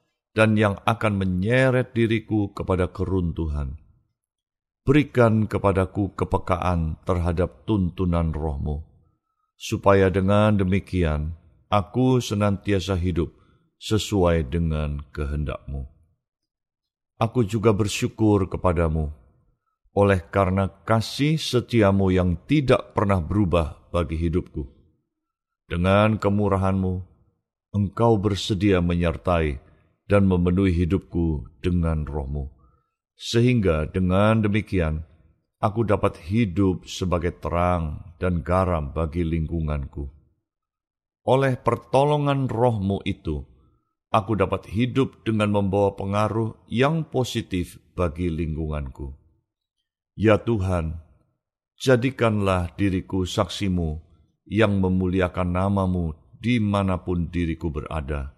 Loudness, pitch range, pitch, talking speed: -23 LUFS, 85-110 Hz, 95 Hz, 85 wpm